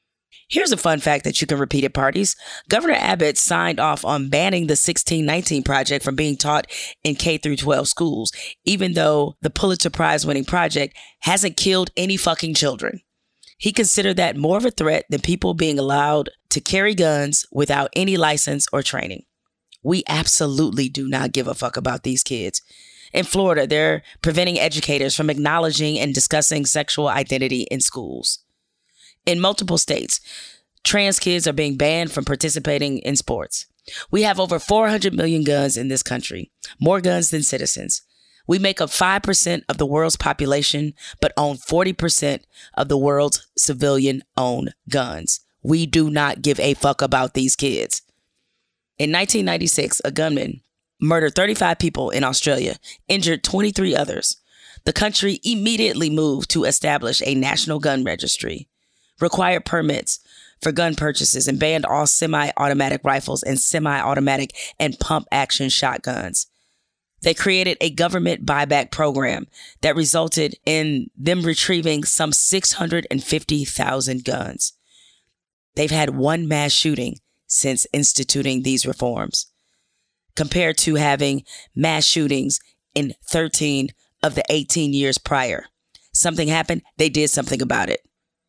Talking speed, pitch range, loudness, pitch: 145 wpm, 140-170 Hz, -19 LUFS, 150 Hz